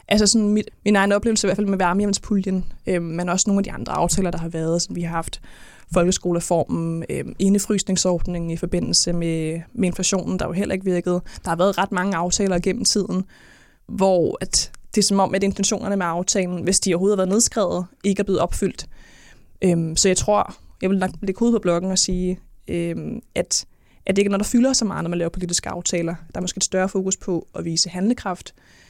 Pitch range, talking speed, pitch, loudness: 175-200 Hz, 220 wpm, 185 Hz, -21 LUFS